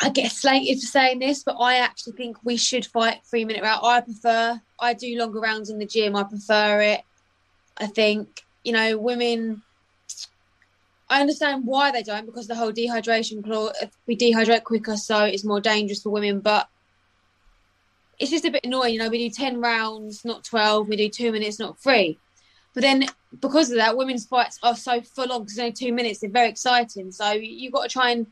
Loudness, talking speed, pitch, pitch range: -22 LUFS, 200 wpm, 230 Hz, 210-245 Hz